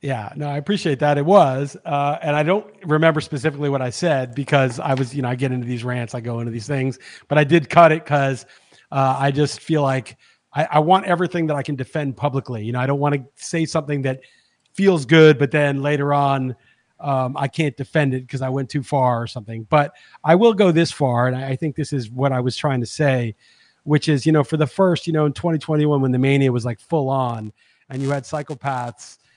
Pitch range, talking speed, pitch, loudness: 130-155 Hz, 240 wpm, 140 Hz, -19 LUFS